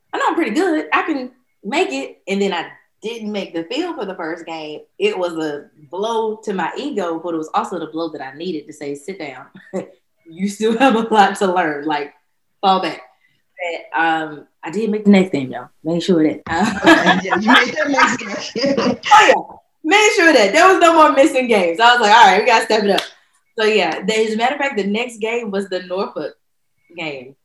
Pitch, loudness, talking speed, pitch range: 200 Hz, -16 LUFS, 215 wpm, 165-245 Hz